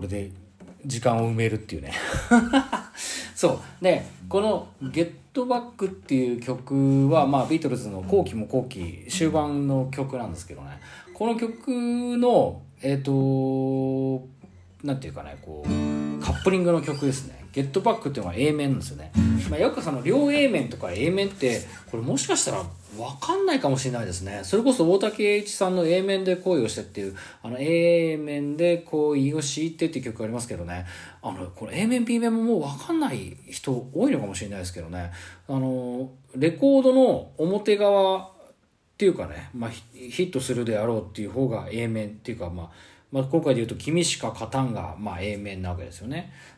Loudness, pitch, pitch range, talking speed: -25 LUFS, 135 Hz, 105-175 Hz, 340 characters per minute